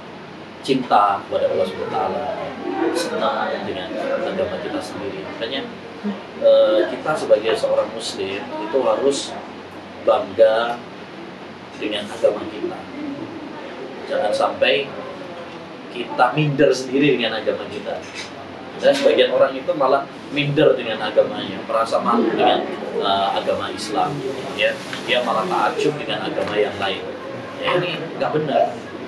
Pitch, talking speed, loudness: 275 Hz, 115 wpm, -20 LUFS